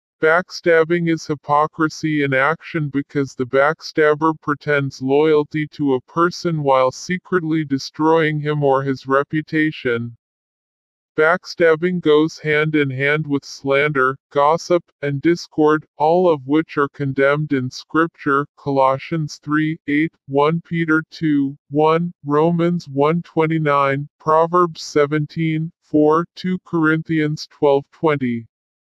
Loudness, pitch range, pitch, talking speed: -18 LUFS, 140-160 Hz, 150 Hz, 110 wpm